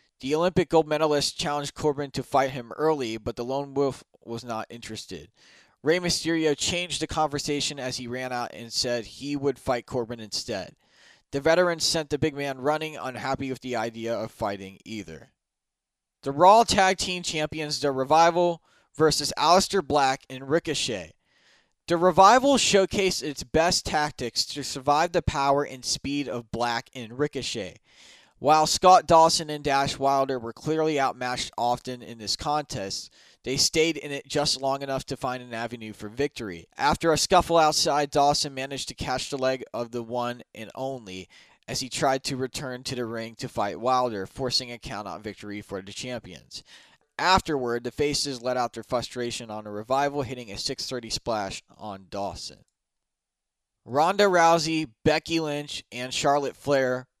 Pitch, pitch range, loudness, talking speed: 135 Hz, 120-155 Hz, -25 LUFS, 165 wpm